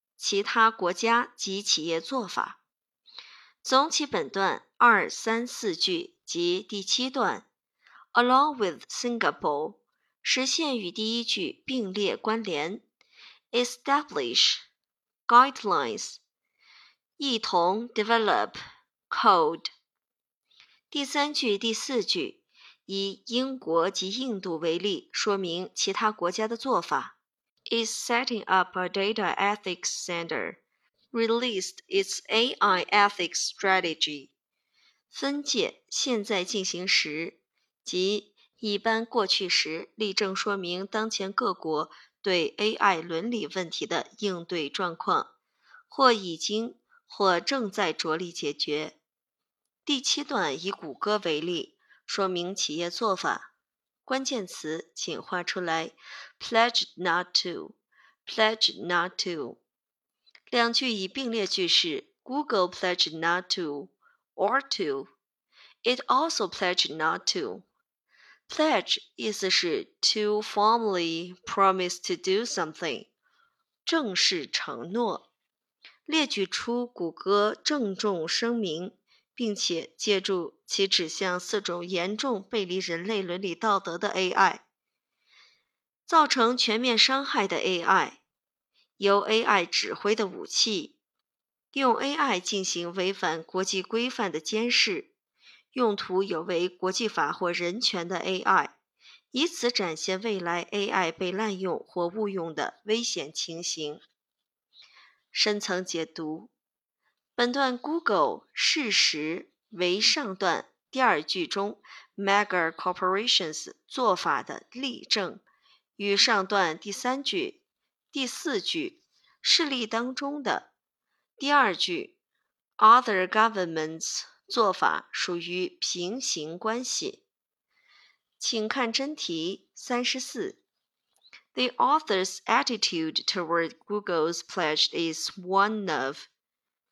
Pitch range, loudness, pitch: 185-255 Hz, -27 LUFS, 210 Hz